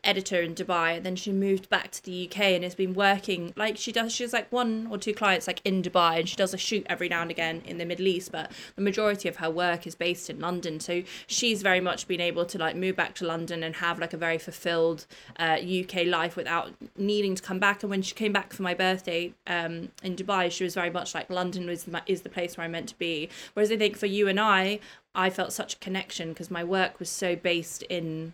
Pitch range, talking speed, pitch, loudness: 170-195 Hz, 260 wpm, 180 Hz, -28 LUFS